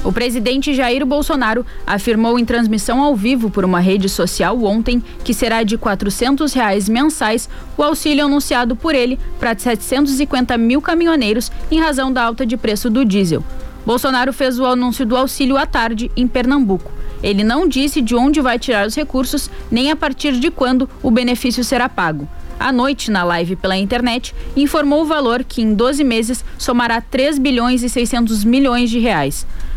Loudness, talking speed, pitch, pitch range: -16 LUFS, 175 wpm, 245 Hz, 230-270 Hz